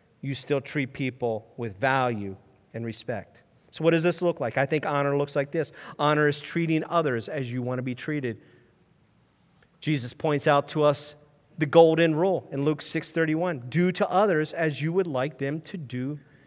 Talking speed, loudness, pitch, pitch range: 185 wpm, -26 LUFS, 145 Hz, 130-160 Hz